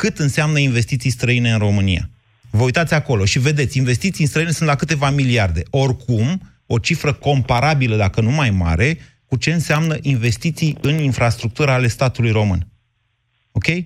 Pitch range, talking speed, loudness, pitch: 115-150 Hz, 155 wpm, -17 LUFS, 130 Hz